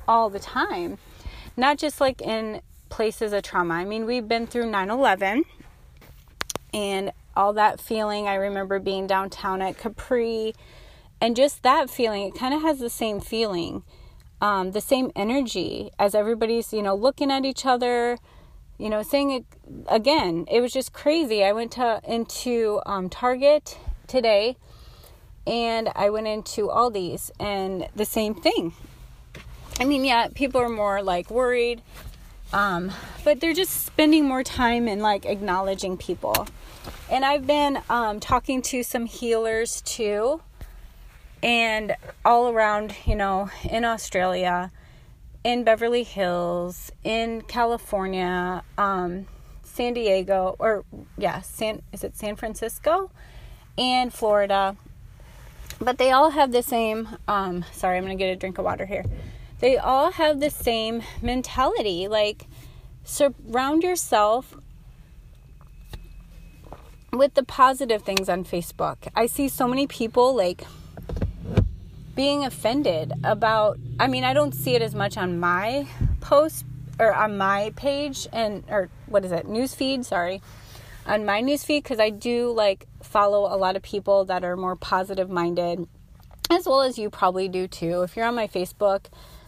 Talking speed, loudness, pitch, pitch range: 145 wpm, -24 LUFS, 220 Hz, 195-250 Hz